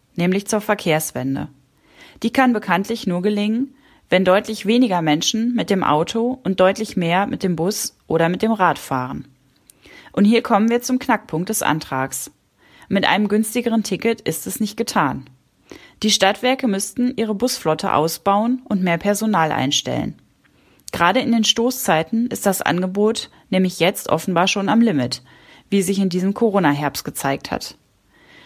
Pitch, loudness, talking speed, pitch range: 200 Hz, -19 LUFS, 150 wpm, 170-230 Hz